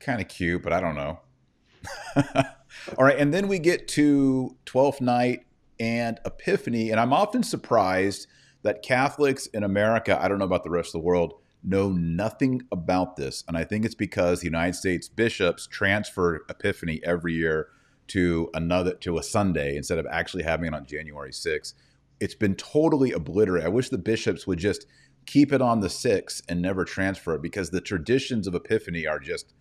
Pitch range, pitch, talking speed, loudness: 85-125 Hz, 95 Hz, 185 wpm, -25 LUFS